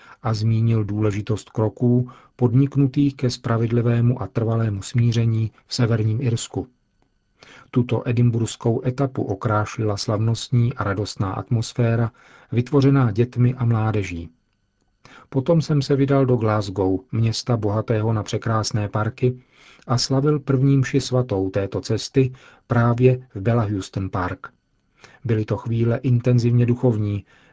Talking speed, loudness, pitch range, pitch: 115 wpm, -21 LUFS, 105-125 Hz, 115 Hz